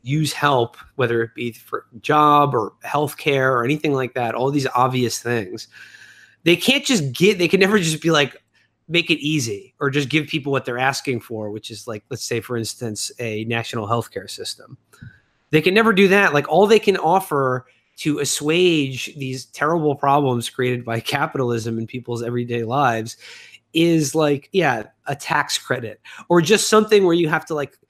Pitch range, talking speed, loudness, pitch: 120-160 Hz, 185 wpm, -19 LUFS, 140 Hz